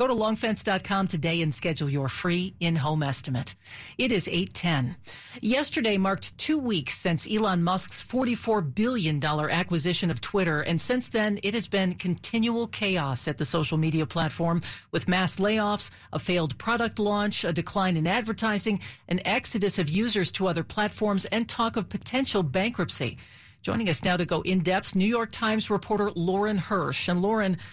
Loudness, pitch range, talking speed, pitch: -27 LUFS, 165-215 Hz, 165 wpm, 190 Hz